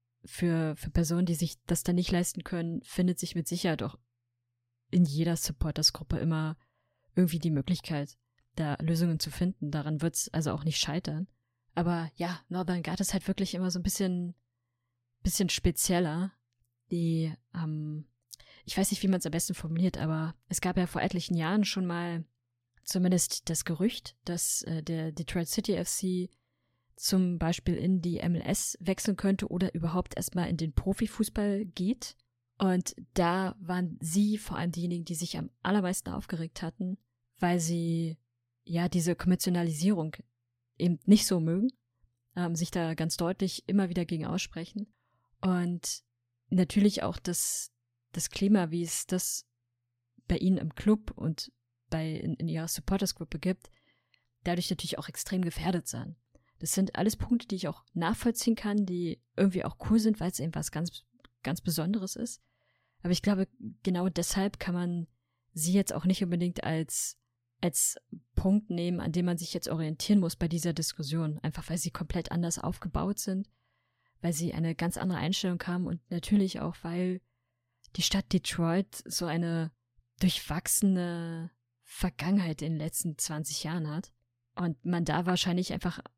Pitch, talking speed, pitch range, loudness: 170 Hz, 160 wpm, 155-185 Hz, -31 LUFS